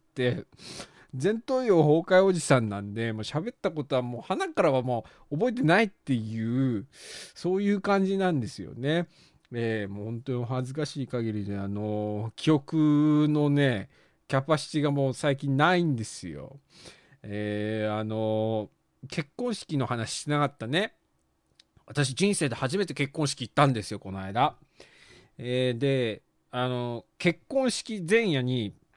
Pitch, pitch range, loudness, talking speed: 135 Hz, 115-160 Hz, -28 LUFS, 280 characters per minute